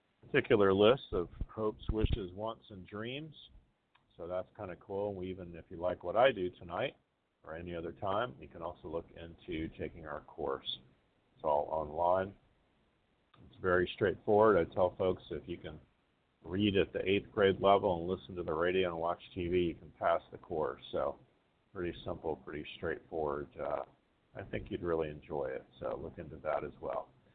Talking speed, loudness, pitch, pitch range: 180 wpm, -35 LUFS, 90 Hz, 85-100 Hz